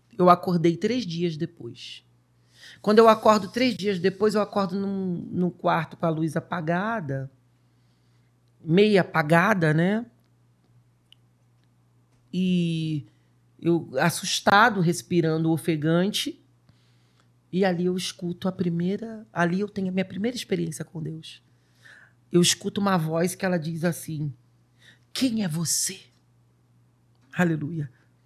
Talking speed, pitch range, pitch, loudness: 115 wpm, 120-190 Hz, 170 Hz, -24 LUFS